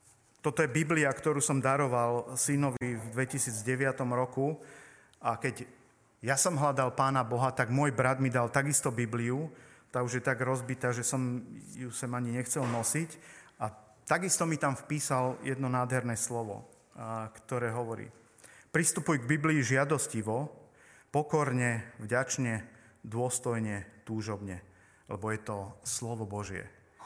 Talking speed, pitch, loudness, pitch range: 130 wpm, 125 Hz, -31 LUFS, 115-135 Hz